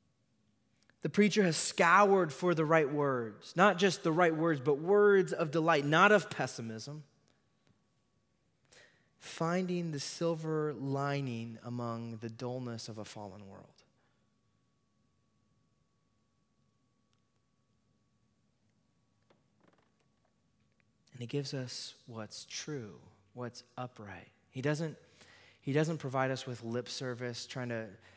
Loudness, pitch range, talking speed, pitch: -32 LUFS, 115-160 Hz, 105 wpm, 125 Hz